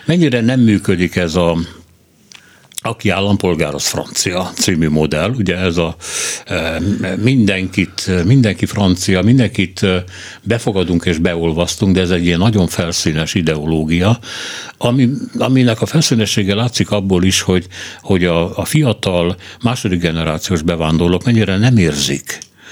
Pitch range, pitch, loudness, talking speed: 85-110 Hz, 95 Hz, -15 LUFS, 120 wpm